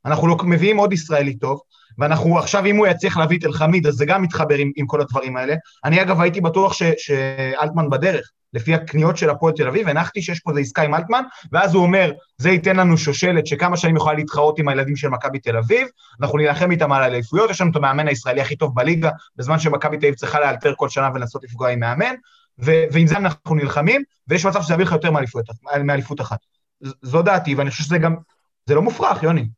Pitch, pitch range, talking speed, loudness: 155 Hz, 140-175 Hz, 195 wpm, -18 LUFS